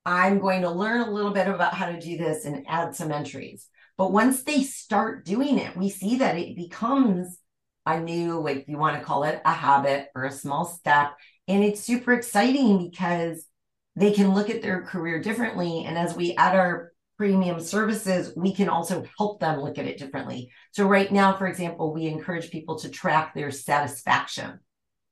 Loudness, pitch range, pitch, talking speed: -25 LUFS, 160-200 Hz, 175 Hz, 195 wpm